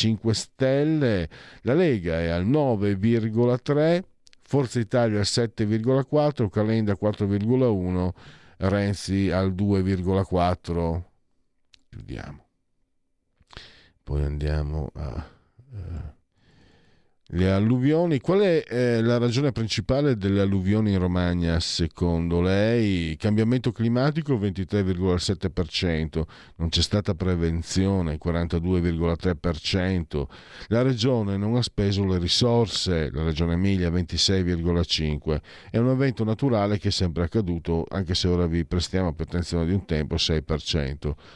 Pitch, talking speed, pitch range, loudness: 95 Hz, 105 wpm, 85-115 Hz, -24 LUFS